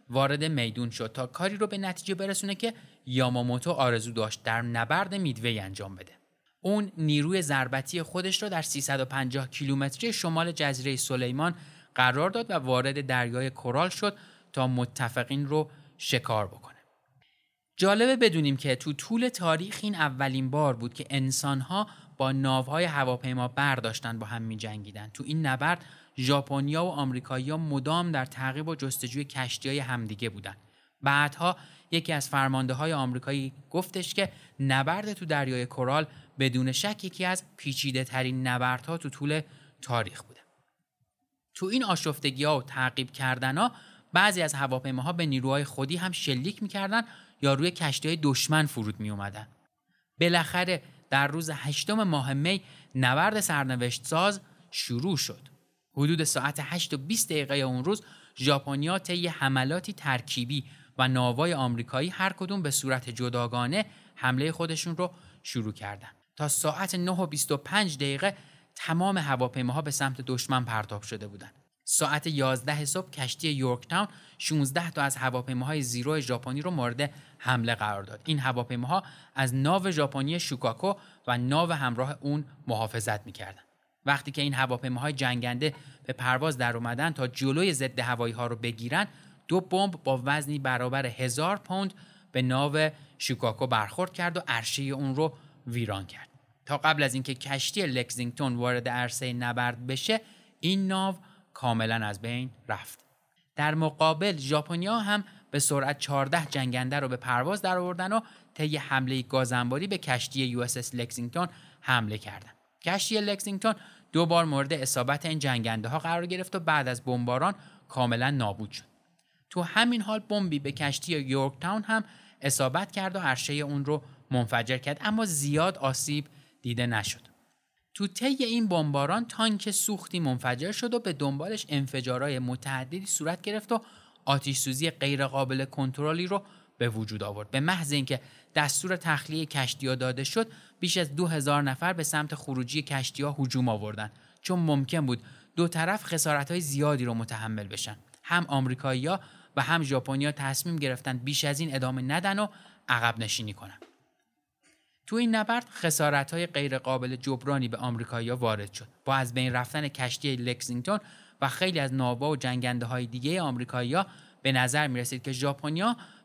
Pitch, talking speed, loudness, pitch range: 140 Hz, 150 wpm, -29 LUFS, 130-170 Hz